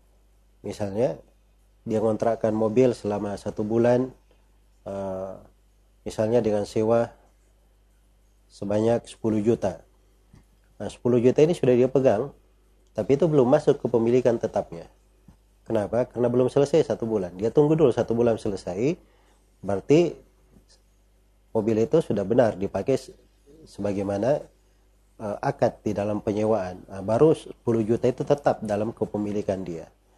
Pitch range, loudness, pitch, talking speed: 100-120 Hz, -24 LUFS, 110 Hz, 115 wpm